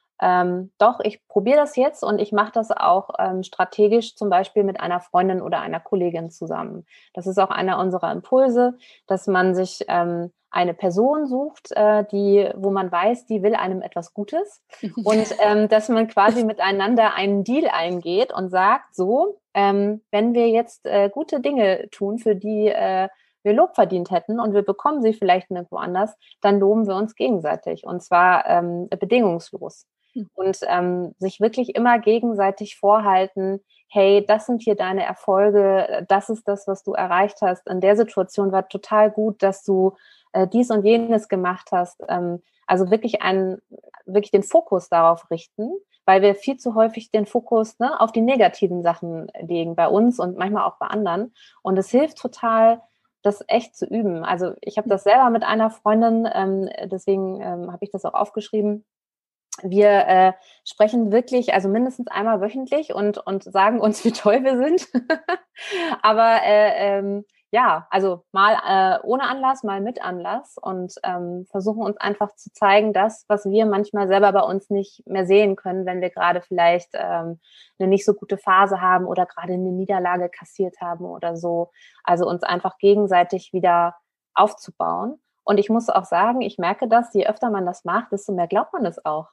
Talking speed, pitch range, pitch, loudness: 180 wpm, 185-225 Hz, 205 Hz, -20 LUFS